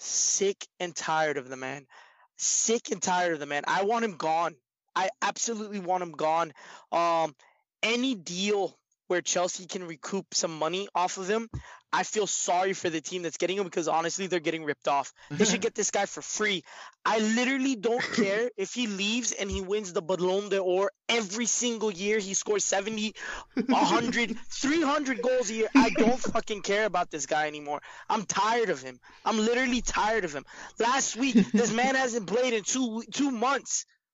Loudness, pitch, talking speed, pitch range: -28 LUFS, 205 Hz, 185 wpm, 180-235 Hz